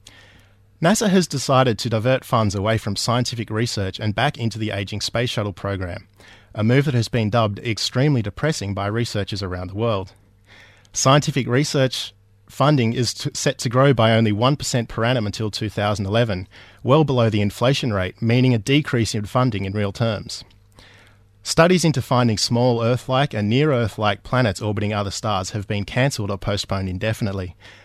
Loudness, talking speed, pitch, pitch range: -20 LUFS, 170 wpm, 110 Hz, 100-125 Hz